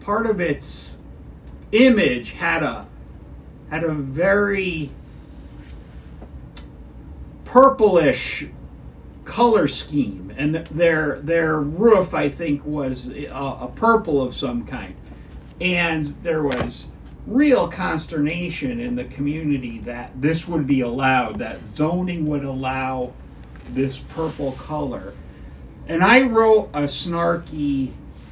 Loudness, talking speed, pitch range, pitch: -20 LUFS, 105 wpm, 105-170 Hz, 145 Hz